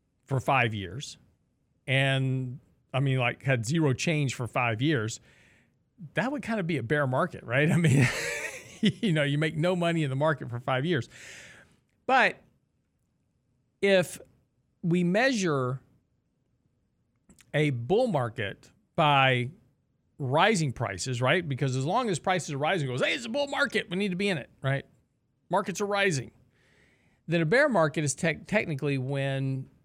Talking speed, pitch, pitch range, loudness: 160 wpm, 140 Hz, 130-170 Hz, -27 LUFS